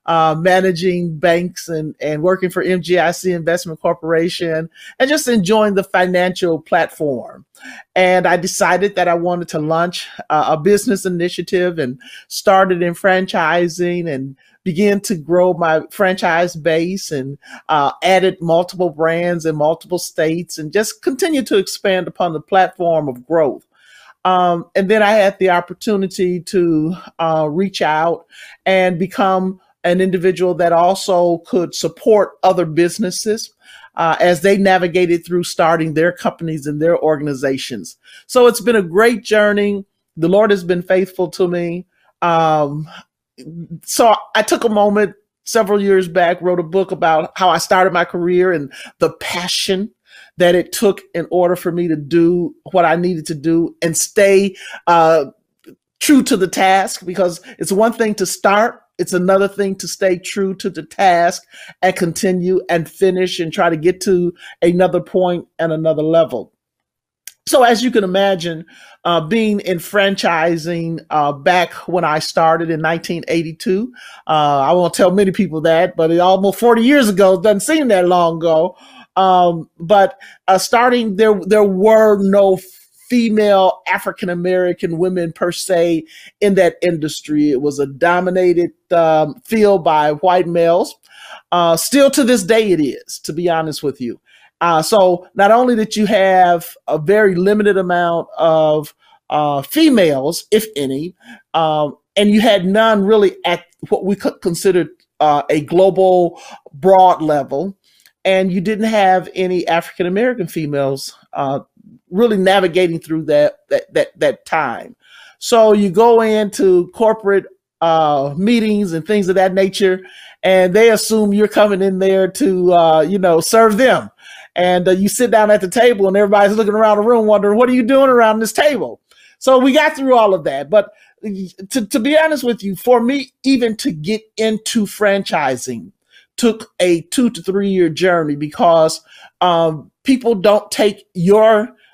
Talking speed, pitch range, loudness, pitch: 160 wpm, 170-205 Hz, -15 LUFS, 185 Hz